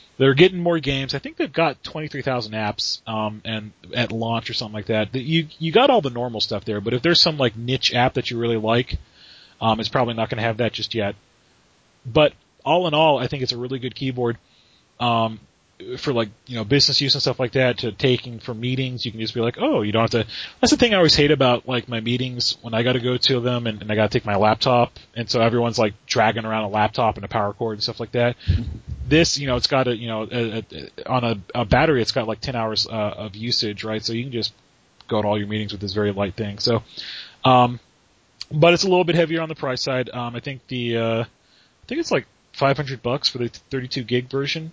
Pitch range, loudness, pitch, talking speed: 110-135 Hz, -21 LUFS, 120 Hz, 260 wpm